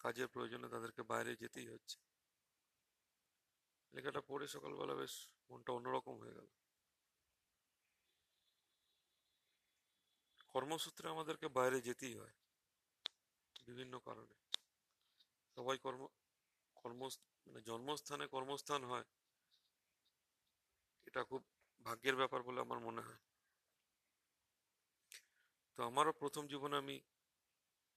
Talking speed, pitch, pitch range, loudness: 85 wpm, 135 Hz, 125-145 Hz, -46 LUFS